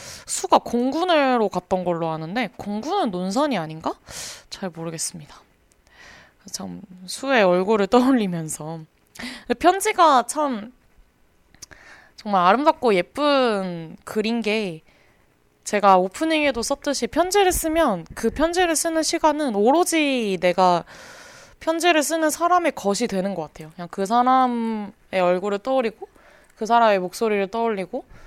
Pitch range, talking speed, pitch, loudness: 180-295 Hz, 265 characters per minute, 225 Hz, -21 LUFS